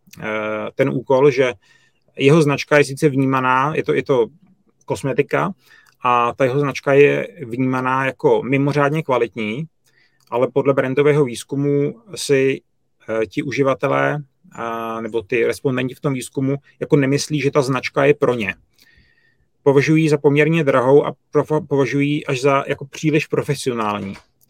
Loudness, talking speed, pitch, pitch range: -18 LUFS, 130 wpm, 140 Hz, 130-145 Hz